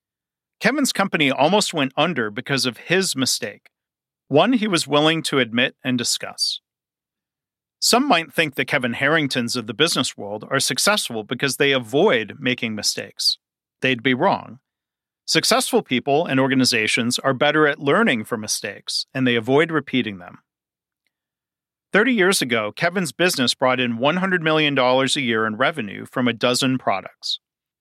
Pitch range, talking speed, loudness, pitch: 125-160 Hz, 150 wpm, -19 LUFS, 135 Hz